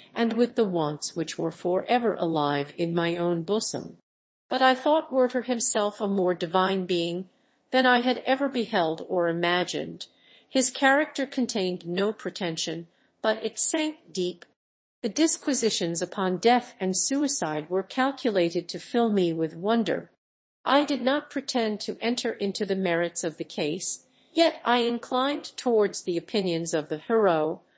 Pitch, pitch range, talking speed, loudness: 205 Hz, 175-250 Hz, 155 wpm, -26 LUFS